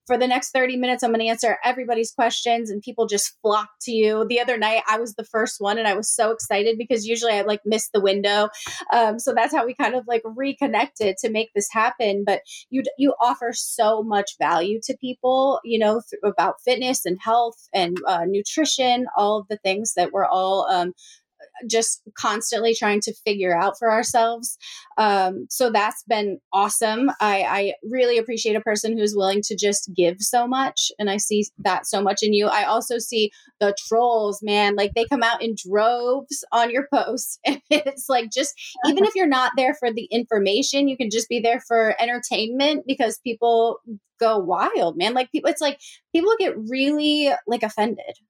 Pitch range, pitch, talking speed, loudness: 210-250 Hz, 230 Hz, 195 wpm, -21 LUFS